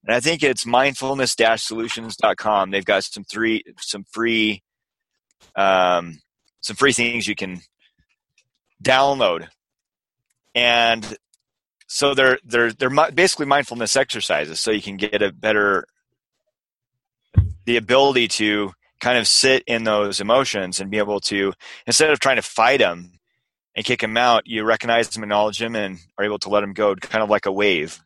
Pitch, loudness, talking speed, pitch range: 115 Hz, -19 LUFS, 155 wpm, 105-130 Hz